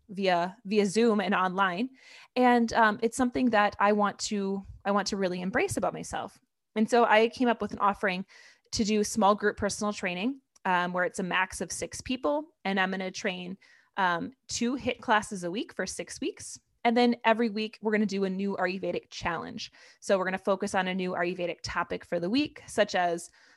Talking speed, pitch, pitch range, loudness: 210 wpm, 205 Hz, 185-230 Hz, -28 LUFS